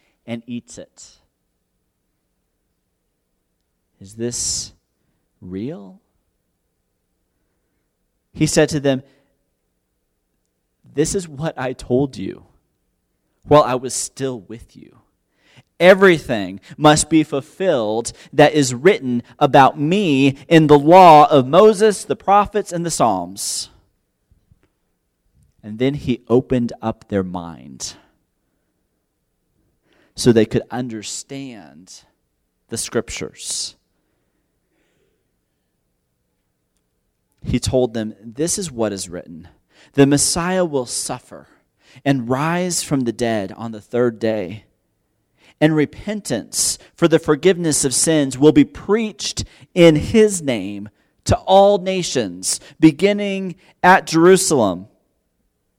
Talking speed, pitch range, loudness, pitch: 100 wpm, 95-155 Hz, -16 LUFS, 125 Hz